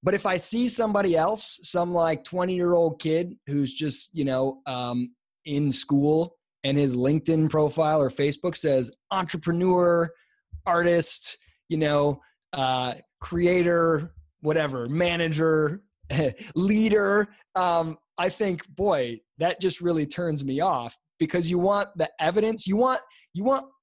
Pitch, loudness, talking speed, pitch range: 165 Hz, -25 LUFS, 135 wpm, 145-185 Hz